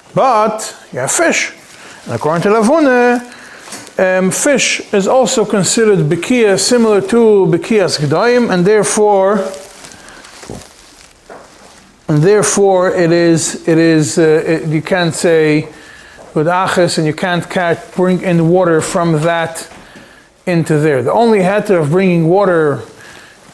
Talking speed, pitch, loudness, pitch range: 125 wpm, 185 Hz, -12 LUFS, 165-210 Hz